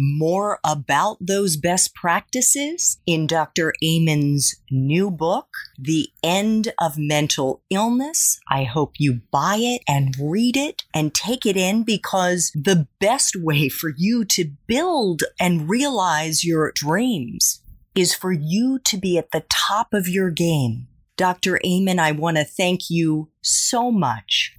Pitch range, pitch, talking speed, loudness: 155-205 Hz, 175 Hz, 145 wpm, -20 LUFS